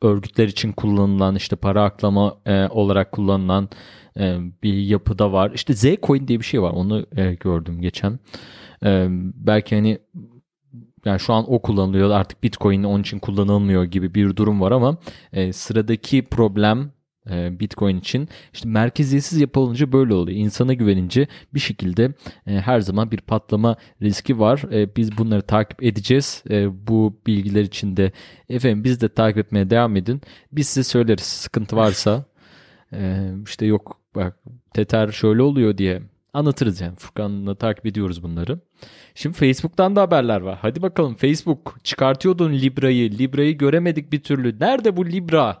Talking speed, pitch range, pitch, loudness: 140 wpm, 100-130 Hz, 110 Hz, -20 LUFS